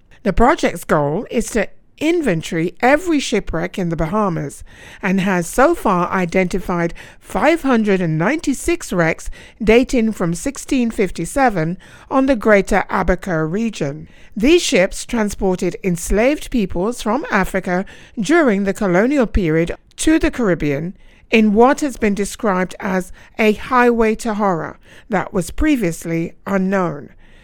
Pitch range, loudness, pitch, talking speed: 180-245 Hz, -17 LUFS, 200 Hz, 120 wpm